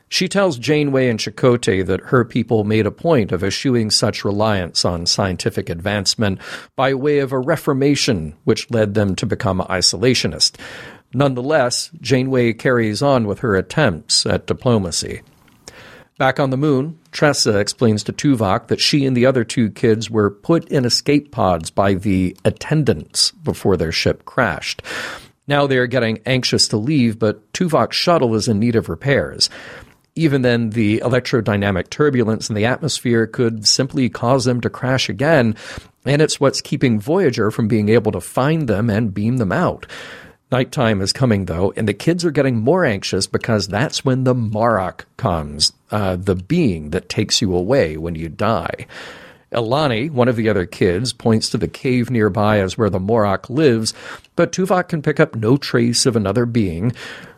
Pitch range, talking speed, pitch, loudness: 105-135 Hz, 170 wpm, 115 Hz, -17 LUFS